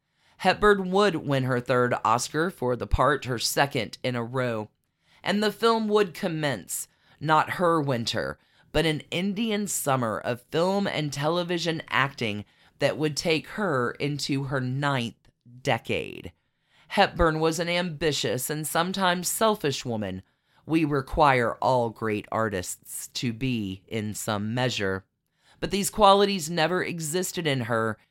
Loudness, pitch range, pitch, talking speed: -26 LUFS, 120-175 Hz, 145 Hz, 135 wpm